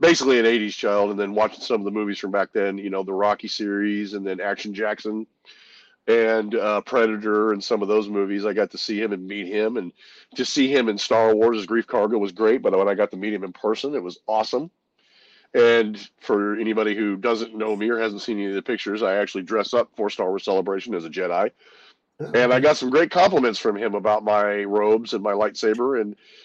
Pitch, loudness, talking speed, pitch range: 105 Hz, -22 LUFS, 230 wpm, 100-110 Hz